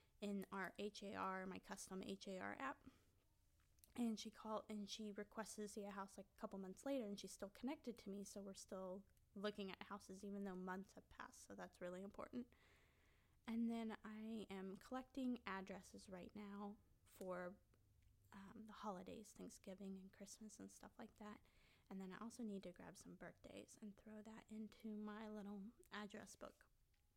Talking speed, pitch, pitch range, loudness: 175 wpm, 205 Hz, 195-220 Hz, -54 LUFS